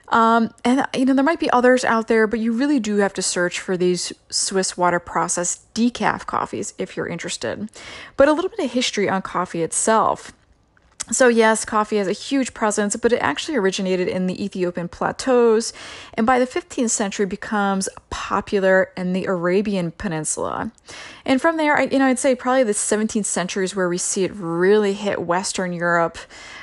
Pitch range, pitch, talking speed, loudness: 185-250 Hz, 210 Hz, 185 wpm, -20 LUFS